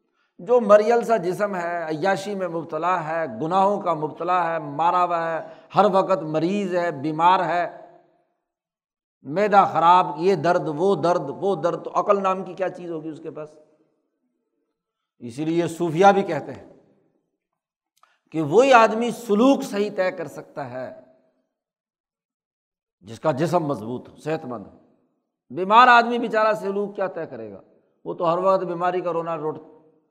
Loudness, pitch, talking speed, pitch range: -21 LUFS, 175 Hz, 155 wpm, 155-195 Hz